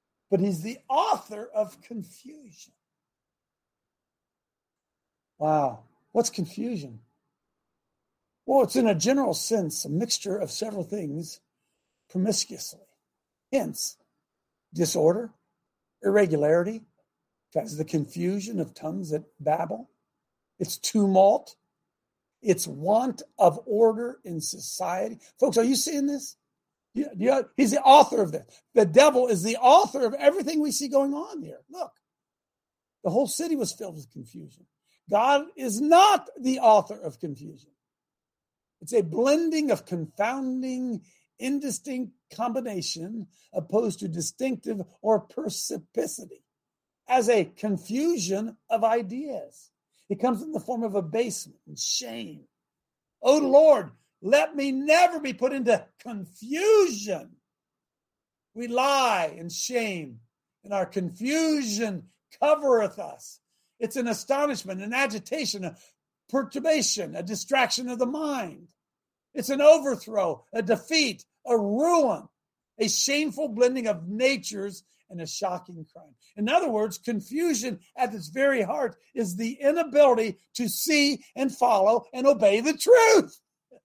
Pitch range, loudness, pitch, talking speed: 190-275 Hz, -25 LUFS, 230 Hz, 120 wpm